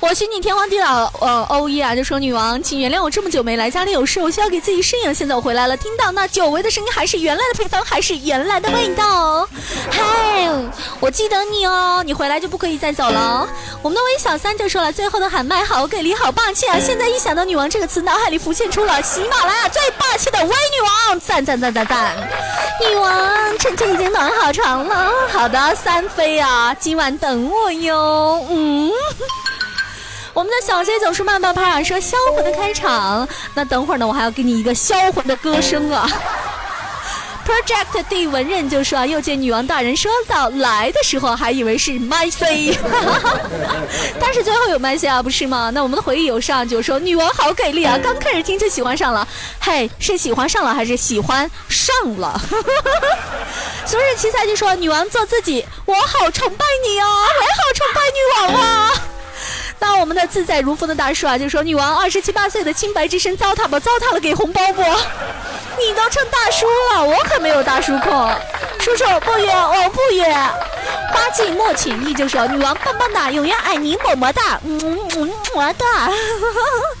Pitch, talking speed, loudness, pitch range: 350 Hz, 300 characters per minute, -16 LUFS, 285-415 Hz